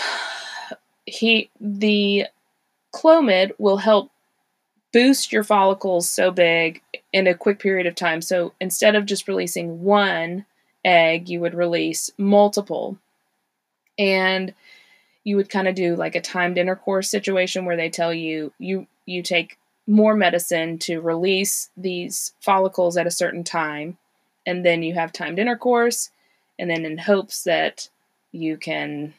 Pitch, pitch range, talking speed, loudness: 185 Hz, 170-205 Hz, 140 wpm, -20 LUFS